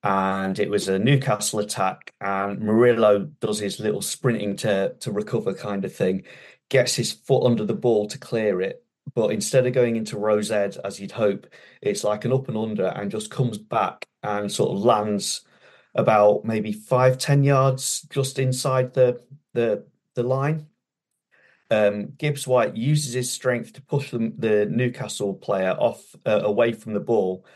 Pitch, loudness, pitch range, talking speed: 115 Hz, -23 LUFS, 105-130 Hz, 170 wpm